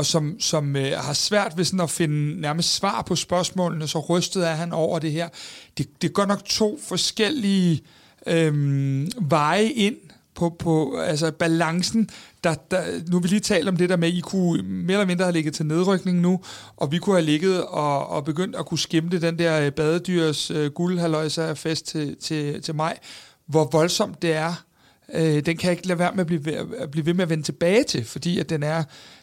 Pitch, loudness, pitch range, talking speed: 170 Hz, -23 LUFS, 155-180 Hz, 210 wpm